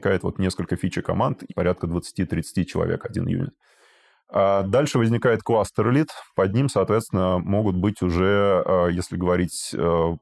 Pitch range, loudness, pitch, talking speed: 90-105 Hz, -23 LUFS, 95 Hz, 125 wpm